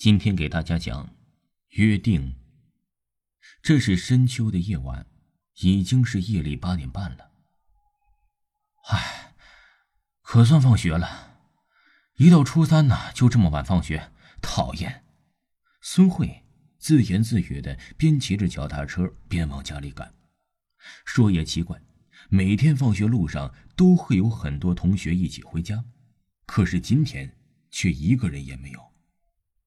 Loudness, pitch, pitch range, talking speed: -22 LUFS, 95 Hz, 85-125 Hz, 190 characters per minute